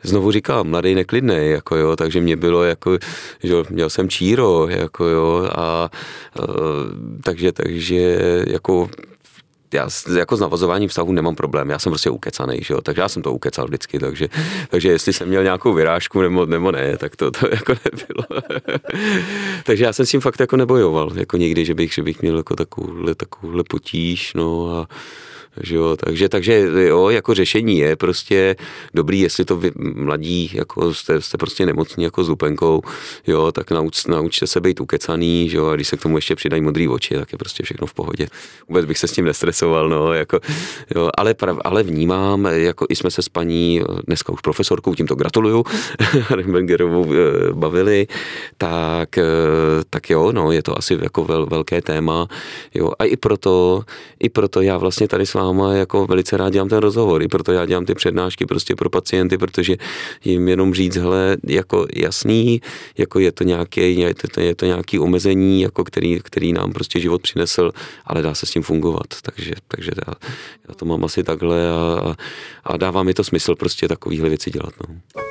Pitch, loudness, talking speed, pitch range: 90 Hz, -18 LUFS, 185 wpm, 85-95 Hz